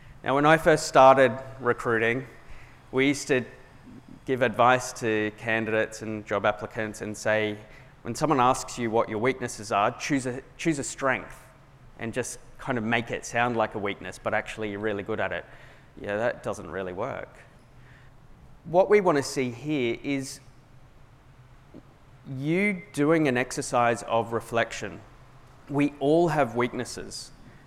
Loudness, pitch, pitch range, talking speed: -26 LUFS, 125 Hz, 115-135 Hz, 150 wpm